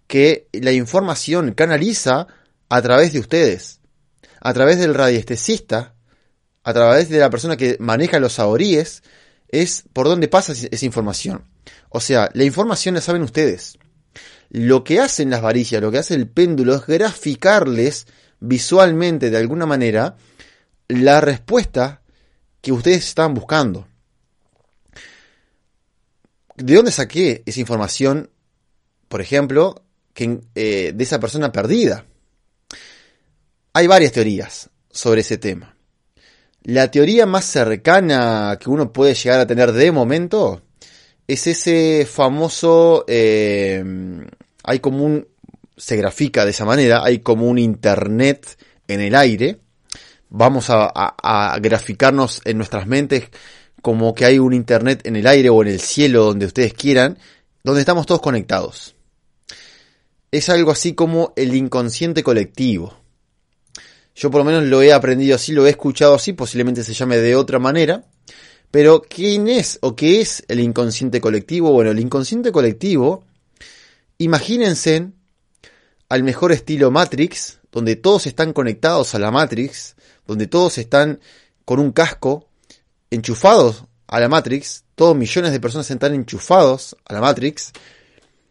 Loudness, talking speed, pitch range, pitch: -16 LUFS, 135 wpm, 120-155 Hz, 135 Hz